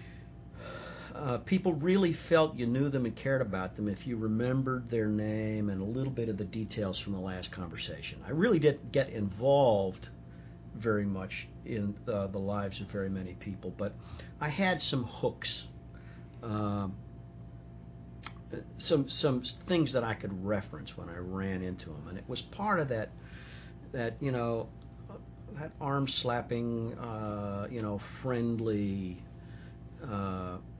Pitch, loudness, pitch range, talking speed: 105 Hz, -33 LUFS, 90-120 Hz, 150 wpm